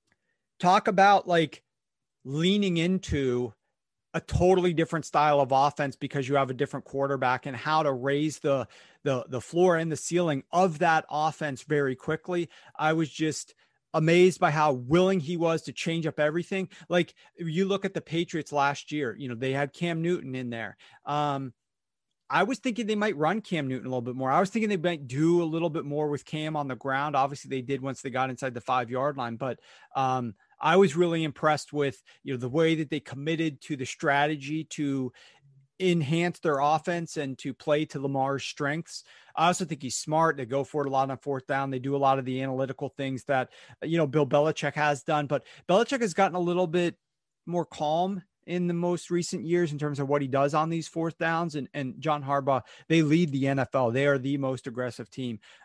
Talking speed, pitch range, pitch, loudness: 210 wpm, 135-170 Hz, 150 Hz, -27 LUFS